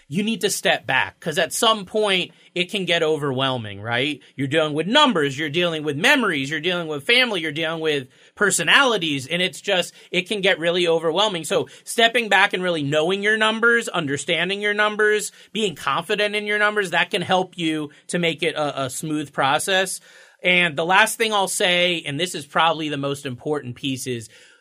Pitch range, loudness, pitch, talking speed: 150-205 Hz, -20 LUFS, 175 Hz, 195 wpm